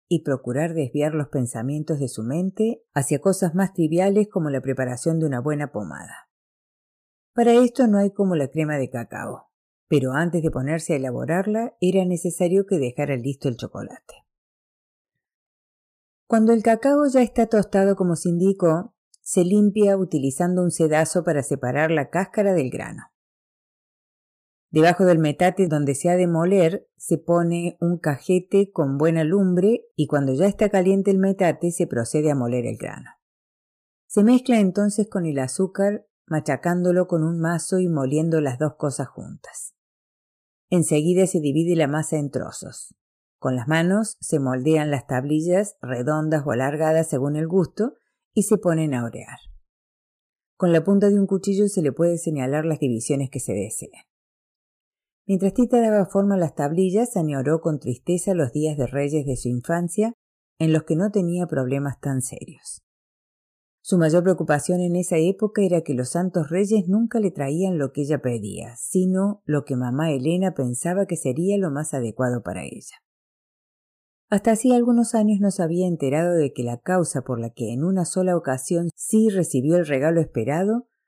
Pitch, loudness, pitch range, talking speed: 165 Hz, -22 LUFS, 145-190 Hz, 165 wpm